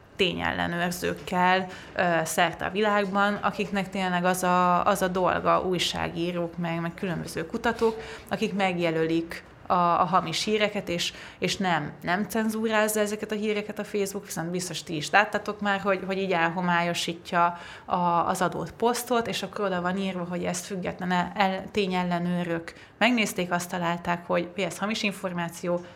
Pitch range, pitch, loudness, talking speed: 175-205 Hz, 185 Hz, -26 LUFS, 145 wpm